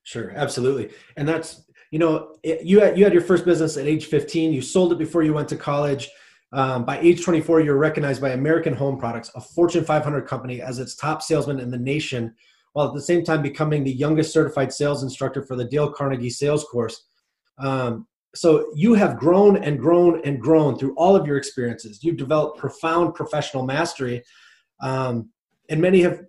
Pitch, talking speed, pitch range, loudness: 150 Hz, 200 wpm, 135-160 Hz, -21 LUFS